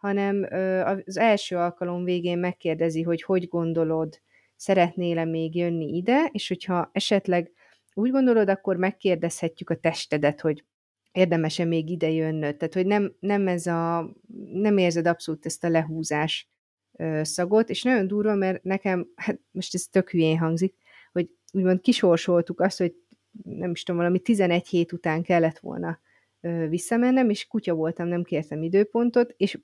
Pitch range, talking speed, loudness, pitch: 165-195 Hz, 150 wpm, -25 LUFS, 180 Hz